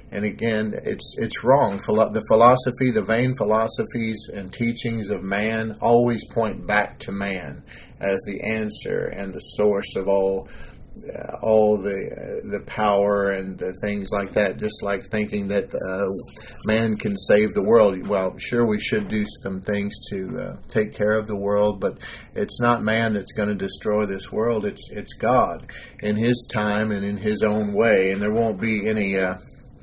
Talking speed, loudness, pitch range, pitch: 180 wpm, -23 LUFS, 100-110 Hz, 105 Hz